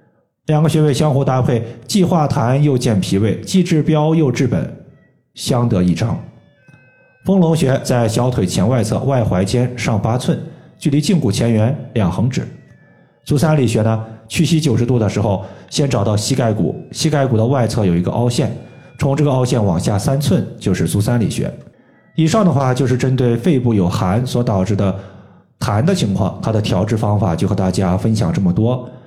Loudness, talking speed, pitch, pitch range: -16 LUFS, 265 characters per minute, 125 Hz, 110-145 Hz